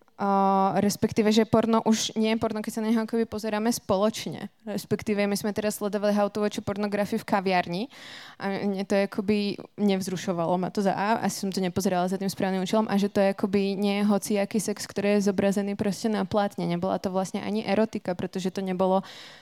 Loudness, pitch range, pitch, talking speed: -26 LUFS, 195-215 Hz, 205 Hz, 195 wpm